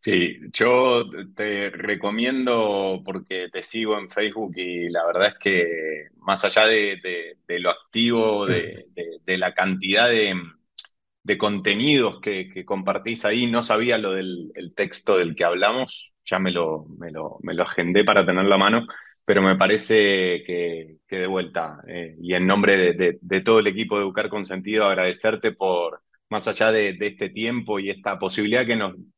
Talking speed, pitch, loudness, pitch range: 180 wpm, 100 Hz, -22 LUFS, 90-110 Hz